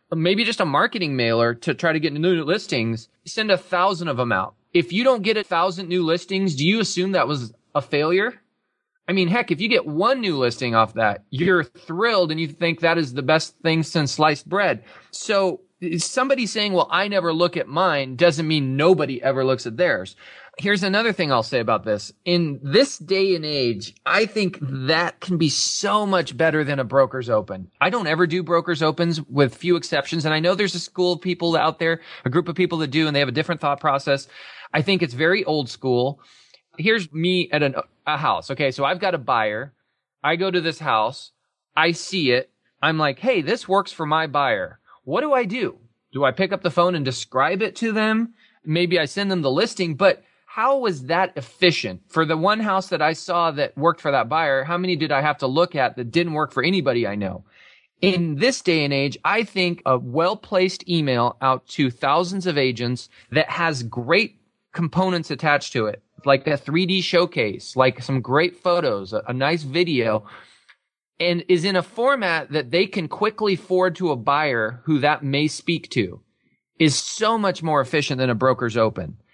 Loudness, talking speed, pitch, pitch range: -21 LUFS, 210 wpm, 165 Hz, 140-185 Hz